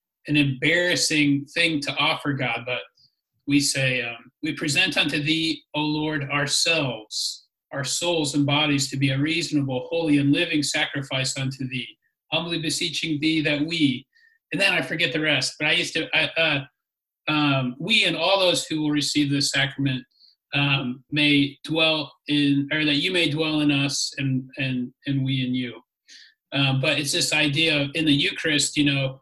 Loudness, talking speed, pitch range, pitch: -22 LUFS, 175 wpm, 140-155 Hz, 145 Hz